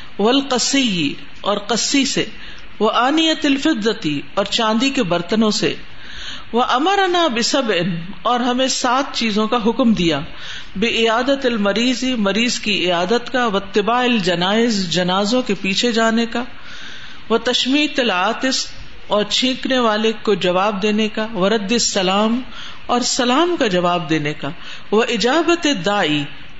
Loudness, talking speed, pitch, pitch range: -17 LUFS, 125 wpm, 225 Hz, 200-250 Hz